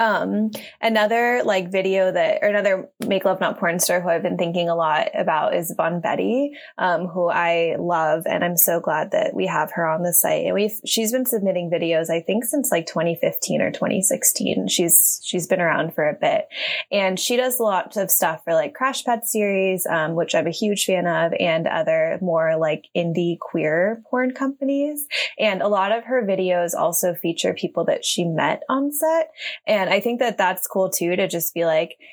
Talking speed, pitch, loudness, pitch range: 200 wpm, 190 Hz, -20 LUFS, 170-240 Hz